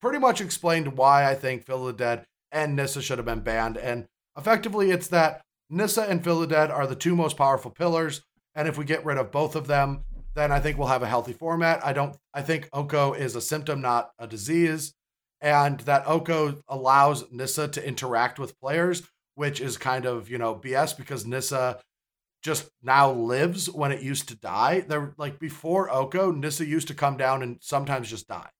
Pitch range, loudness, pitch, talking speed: 130-160 Hz, -25 LUFS, 140 Hz, 205 wpm